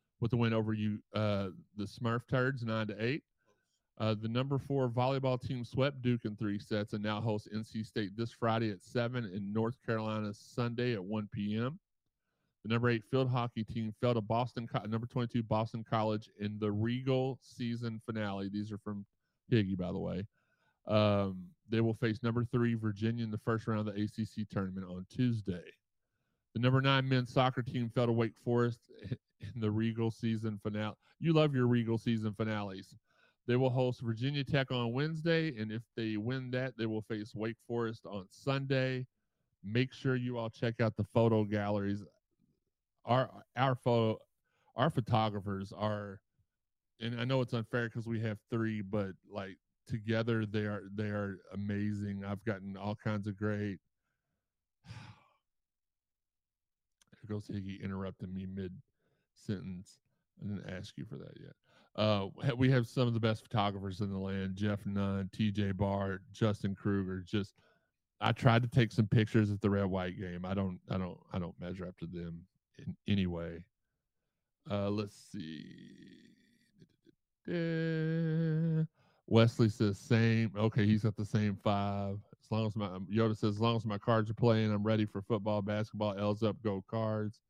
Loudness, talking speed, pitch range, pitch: -35 LUFS, 170 wpm, 105-120 Hz, 110 Hz